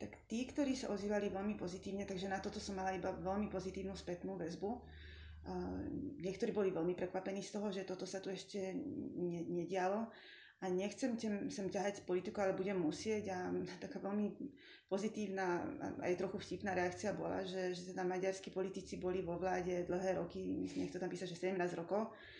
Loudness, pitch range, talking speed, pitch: -42 LUFS, 180-205 Hz, 180 wpm, 190 Hz